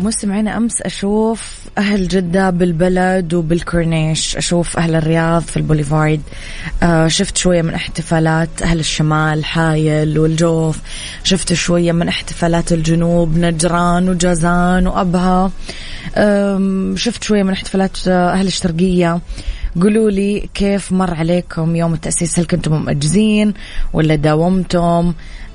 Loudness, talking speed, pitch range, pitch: -15 LUFS, 110 wpm, 165-190 Hz, 175 Hz